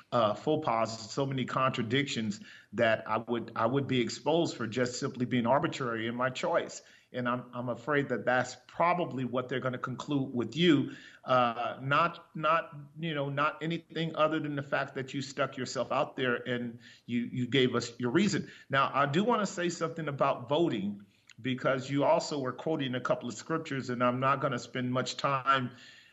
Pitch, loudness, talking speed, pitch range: 130 Hz, -31 LUFS, 195 wpm, 120-150 Hz